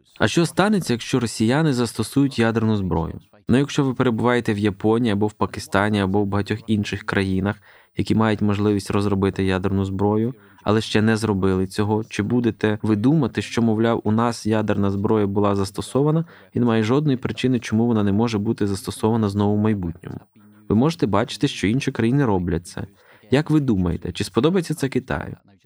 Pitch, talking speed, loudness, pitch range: 110 Hz, 170 wpm, -21 LUFS, 100-120 Hz